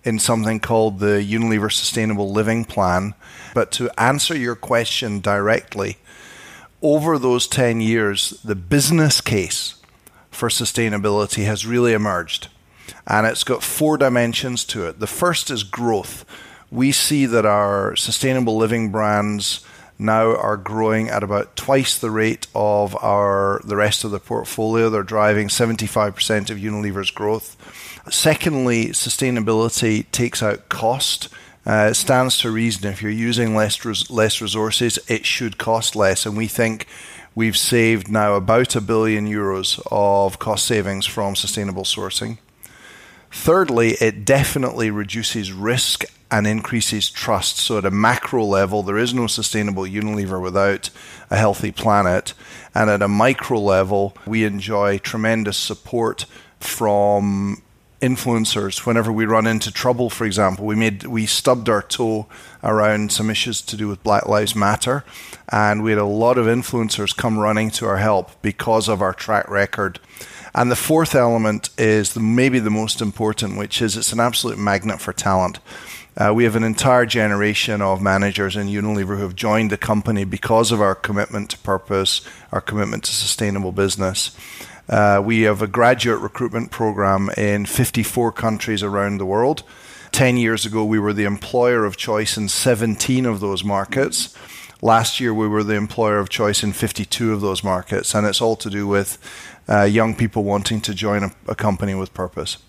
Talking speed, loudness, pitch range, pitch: 160 wpm, -19 LUFS, 100-115 Hz, 110 Hz